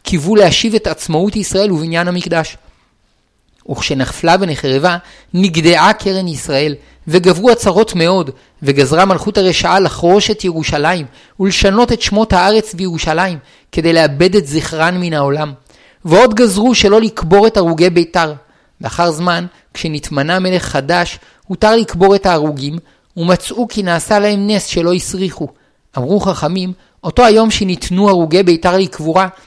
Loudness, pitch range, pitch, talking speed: -12 LUFS, 160-200 Hz, 180 Hz, 130 wpm